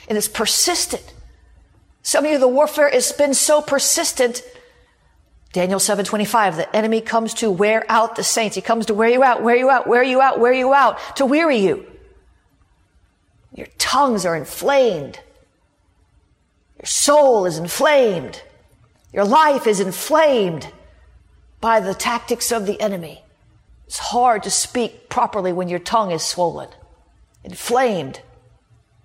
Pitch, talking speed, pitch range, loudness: 230 Hz, 145 wpm, 200-275 Hz, -17 LUFS